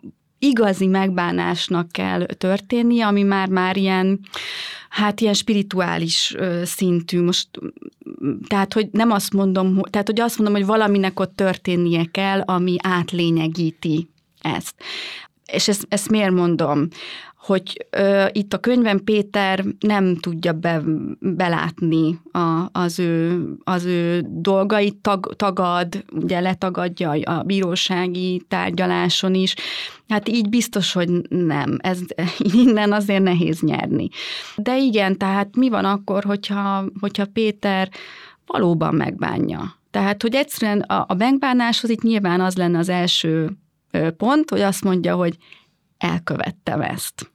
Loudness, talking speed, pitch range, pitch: -20 LUFS, 125 wpm, 175-205 Hz, 190 Hz